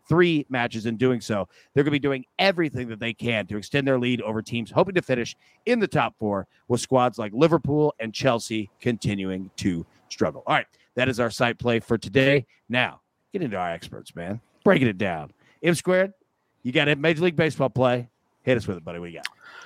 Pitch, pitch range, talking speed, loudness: 125 Hz, 110-145 Hz, 215 wpm, -24 LUFS